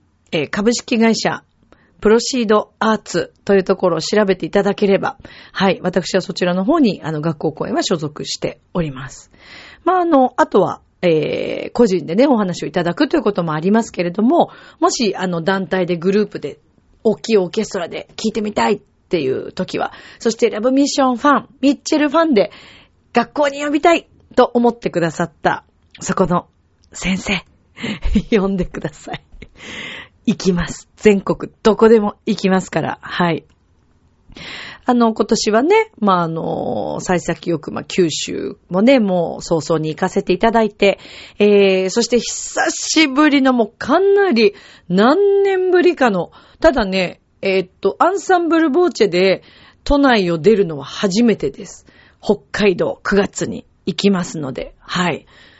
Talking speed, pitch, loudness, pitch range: 310 characters per minute, 210 Hz, -17 LUFS, 180-250 Hz